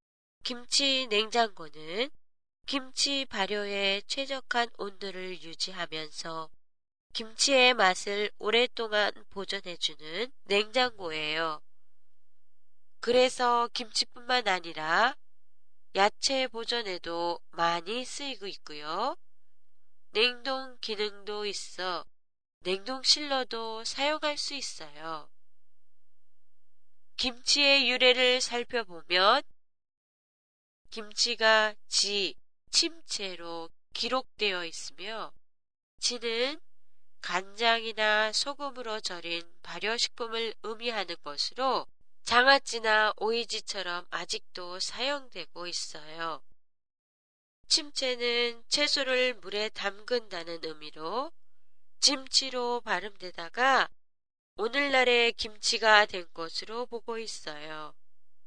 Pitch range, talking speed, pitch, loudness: 180-250 Hz, 195 characters per minute, 220 Hz, -28 LUFS